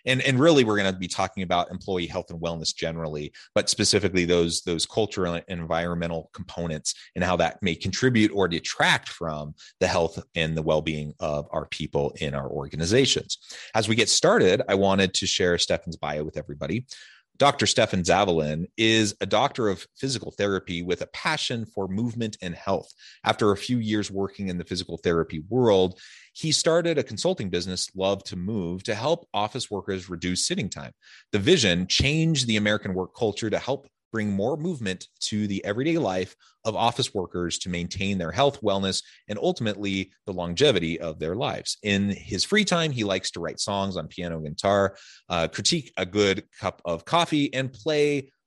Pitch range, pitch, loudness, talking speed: 85-110 Hz, 95 Hz, -25 LUFS, 180 wpm